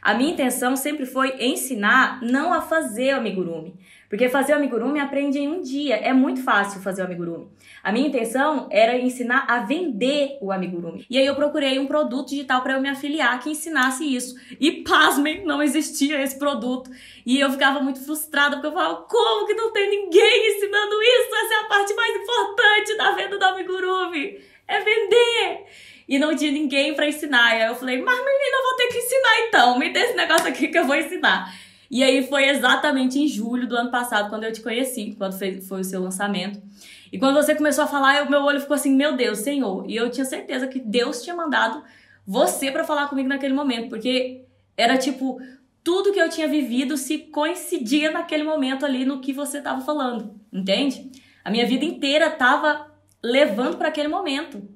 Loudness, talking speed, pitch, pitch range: -21 LUFS, 200 wpm, 280 Hz, 250-315 Hz